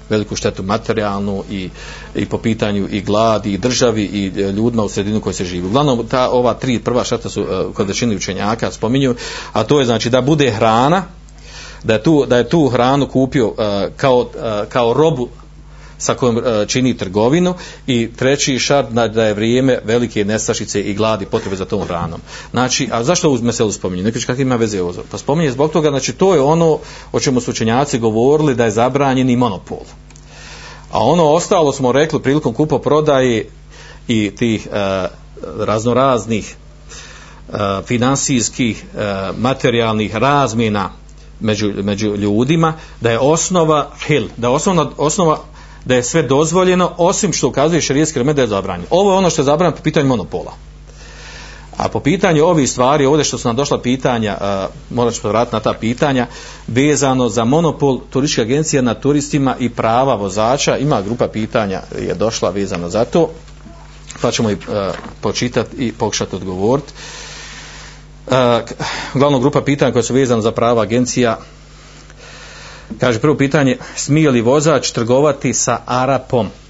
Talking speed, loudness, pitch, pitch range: 160 wpm, -15 LUFS, 125 Hz, 110-140 Hz